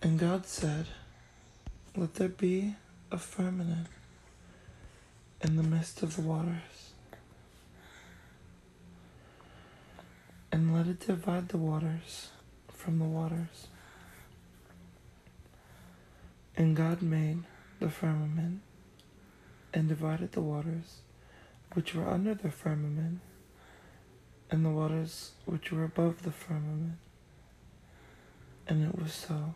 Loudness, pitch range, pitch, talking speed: -34 LUFS, 150-170 Hz, 160 Hz, 100 wpm